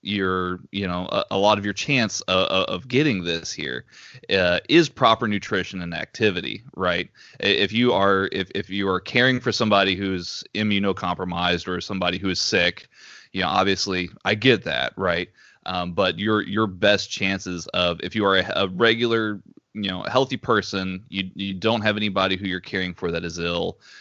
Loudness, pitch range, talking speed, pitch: -22 LUFS, 90-105 Hz, 185 wpm, 95 Hz